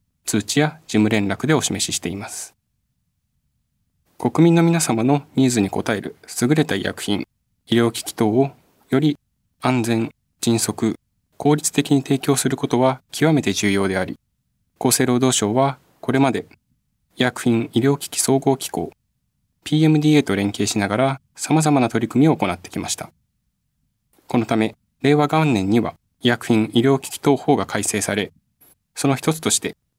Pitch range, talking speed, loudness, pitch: 110-145 Hz, 290 characters per minute, -20 LUFS, 130 Hz